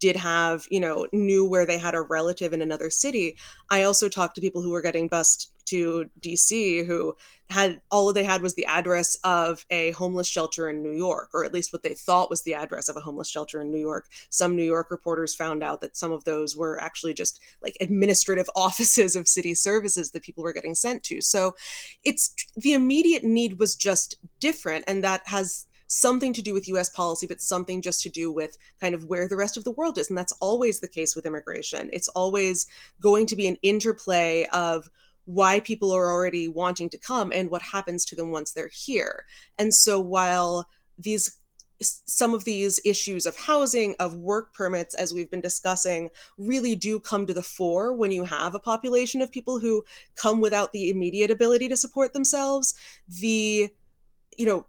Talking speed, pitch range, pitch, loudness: 200 wpm, 170-210 Hz, 185 Hz, -25 LUFS